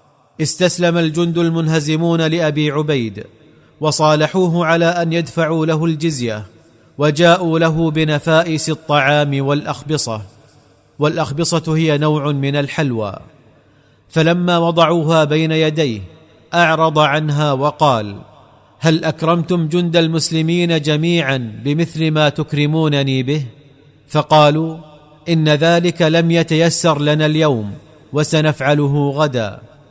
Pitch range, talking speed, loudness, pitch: 145-165 Hz, 90 wpm, -15 LUFS, 155 Hz